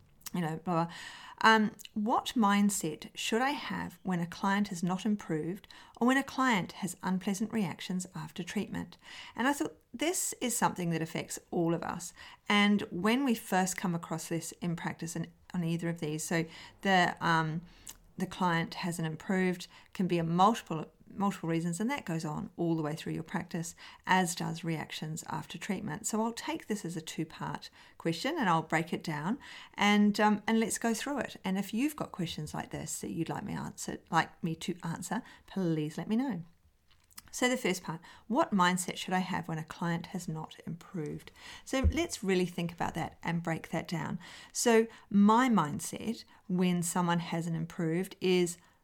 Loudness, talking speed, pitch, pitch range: -32 LUFS, 185 wpm, 185 Hz, 165-215 Hz